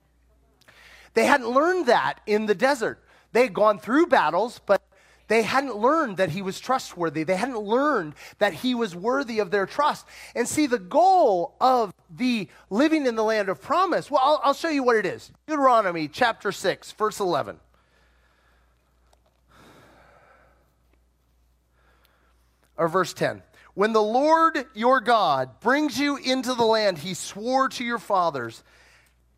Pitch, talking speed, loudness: 210 Hz, 150 wpm, -23 LUFS